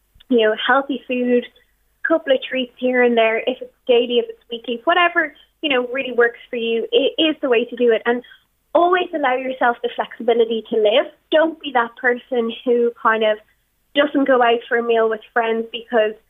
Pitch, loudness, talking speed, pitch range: 245 Hz, -18 LUFS, 205 wpm, 230-275 Hz